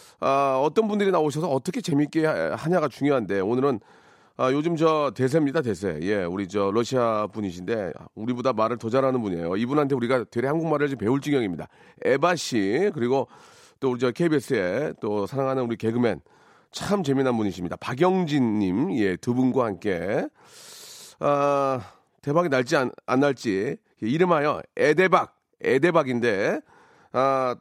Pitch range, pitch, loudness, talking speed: 120-155 Hz, 135 Hz, -24 LUFS, 330 characters per minute